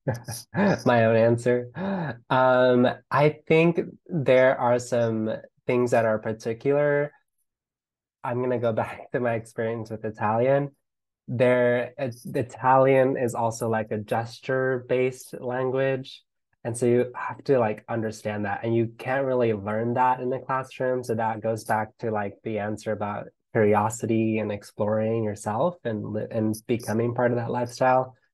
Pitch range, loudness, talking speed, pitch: 110-130 Hz, -25 LUFS, 145 wpm, 120 Hz